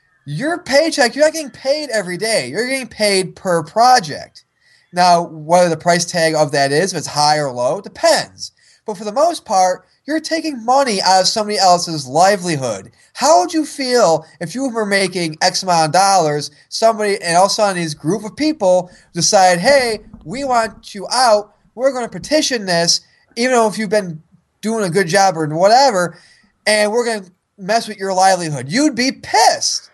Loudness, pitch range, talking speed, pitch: -15 LUFS, 175-245 Hz, 190 wpm, 200 Hz